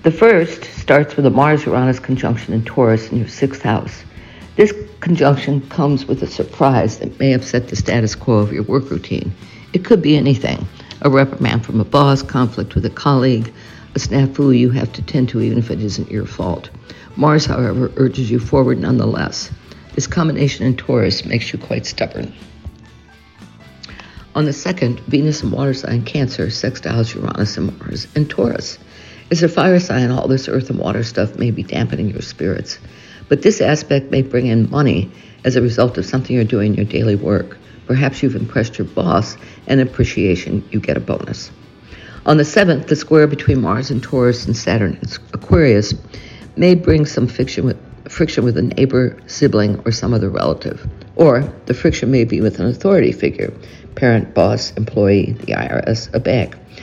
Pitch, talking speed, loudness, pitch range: 125 Hz, 180 wpm, -16 LUFS, 110-140 Hz